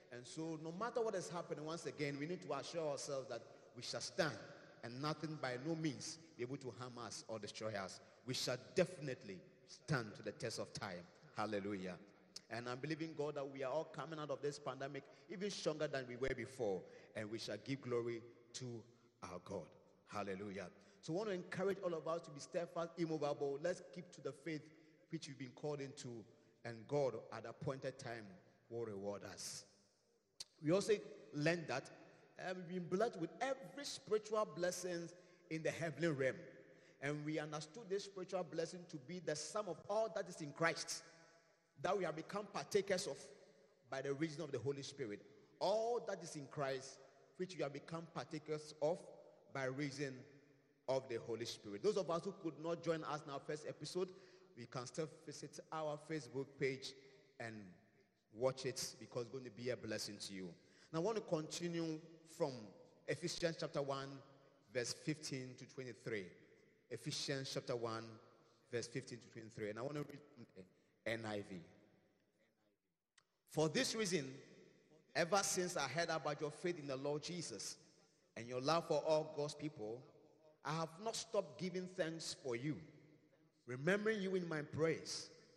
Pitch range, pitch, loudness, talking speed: 130-170 Hz, 150 Hz, -45 LUFS, 175 wpm